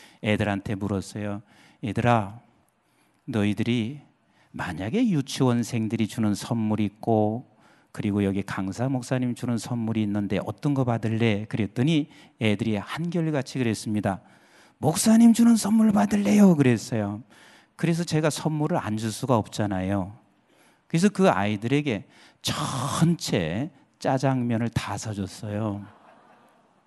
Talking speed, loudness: 270 characters per minute, -25 LUFS